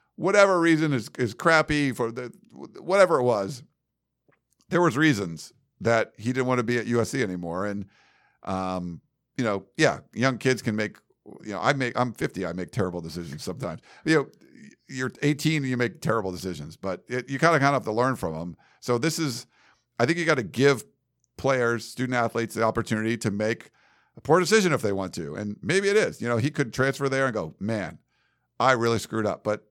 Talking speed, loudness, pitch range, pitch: 210 wpm, -25 LUFS, 105-140 Hz, 120 Hz